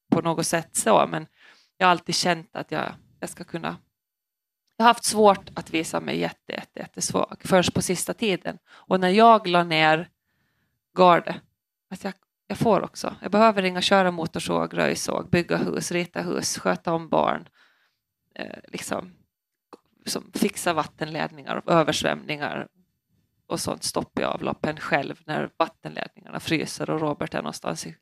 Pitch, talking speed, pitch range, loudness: 175 Hz, 155 wpm, 160-195 Hz, -24 LUFS